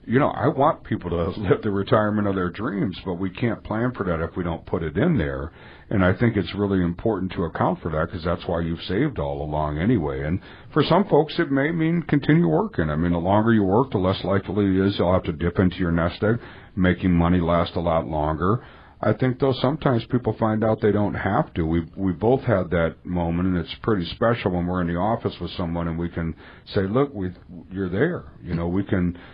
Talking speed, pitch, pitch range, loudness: 240 wpm, 95 Hz, 85-110 Hz, -23 LUFS